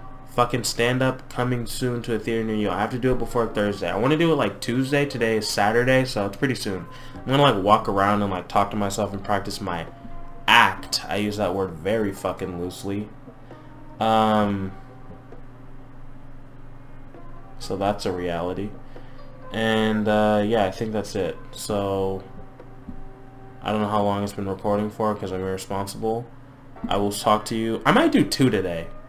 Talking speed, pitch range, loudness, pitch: 180 wpm, 100-130 Hz, -23 LUFS, 110 Hz